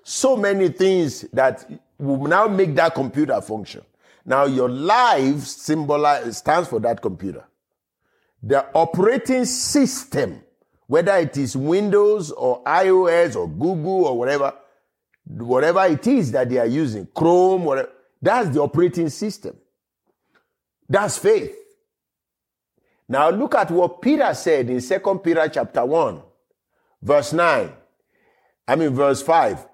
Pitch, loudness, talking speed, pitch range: 170 Hz, -19 LUFS, 125 wpm, 140-200 Hz